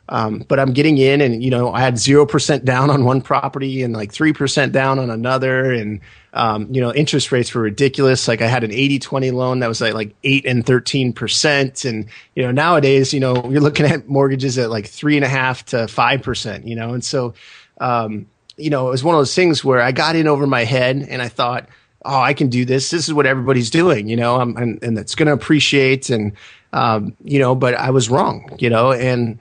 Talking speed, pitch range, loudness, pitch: 235 wpm, 120-140 Hz, -16 LUFS, 130 Hz